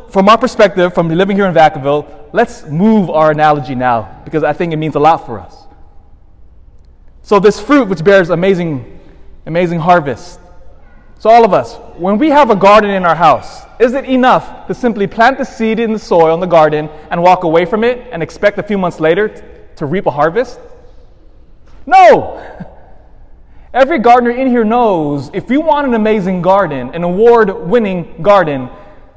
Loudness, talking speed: -11 LUFS, 180 wpm